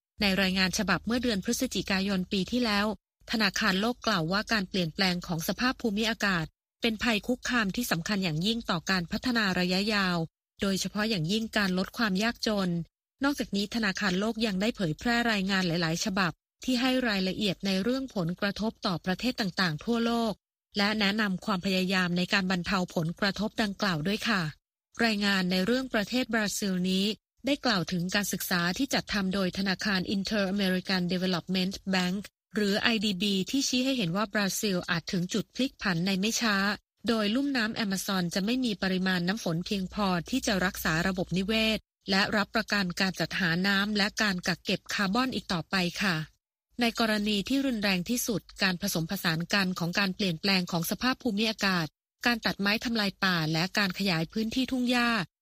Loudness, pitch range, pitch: -28 LUFS, 185-225 Hz, 200 Hz